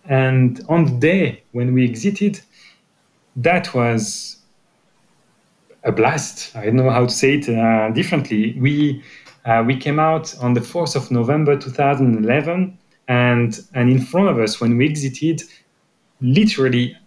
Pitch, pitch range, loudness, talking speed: 130 Hz, 120-160 Hz, -18 LUFS, 145 wpm